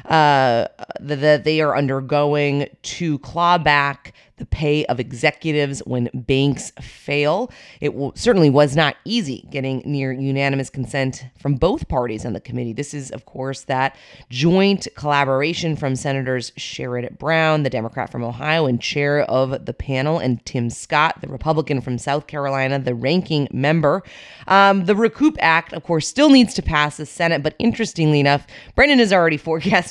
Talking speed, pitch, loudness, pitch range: 165 wpm, 145 Hz, -19 LUFS, 135-160 Hz